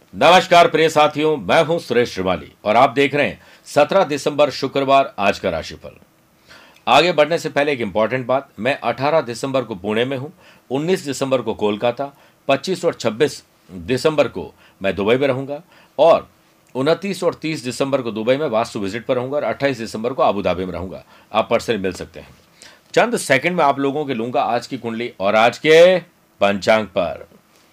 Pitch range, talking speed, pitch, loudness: 120-155 Hz, 180 wpm, 140 Hz, -18 LUFS